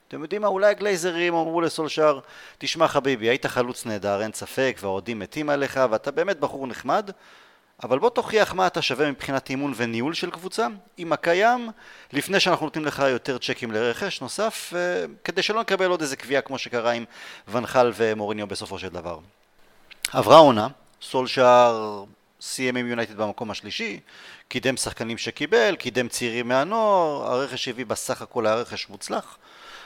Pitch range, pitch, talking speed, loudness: 120-170 Hz, 135 Hz, 155 wpm, -23 LUFS